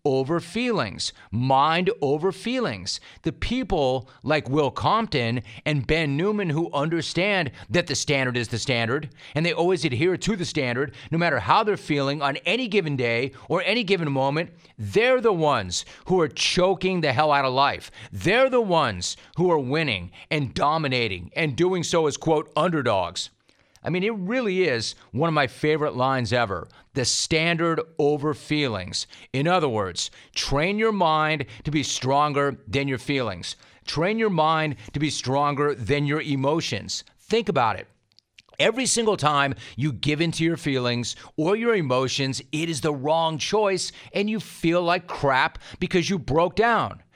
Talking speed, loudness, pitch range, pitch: 165 wpm, -23 LUFS, 130-175 Hz, 150 Hz